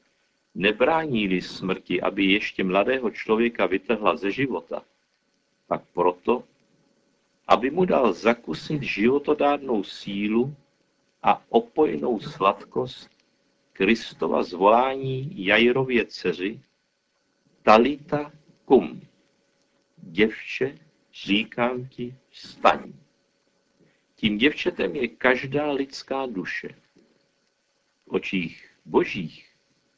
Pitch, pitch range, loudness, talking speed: 125 Hz, 105-140 Hz, -24 LUFS, 80 wpm